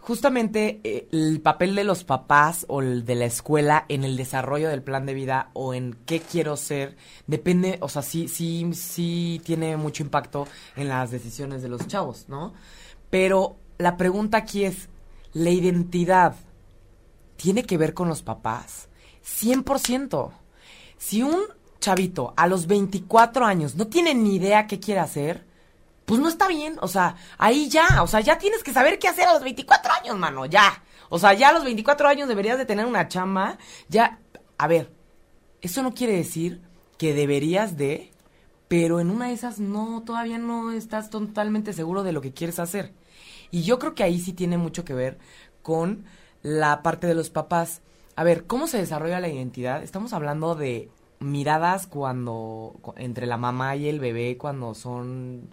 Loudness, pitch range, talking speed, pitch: -23 LUFS, 140-210 Hz, 175 wpm, 170 Hz